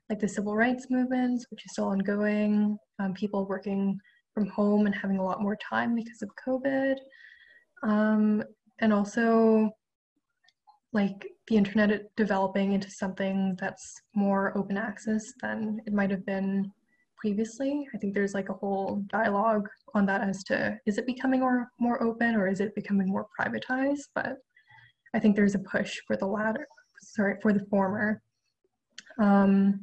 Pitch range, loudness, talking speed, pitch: 200-240 Hz, -28 LUFS, 155 wpm, 210 Hz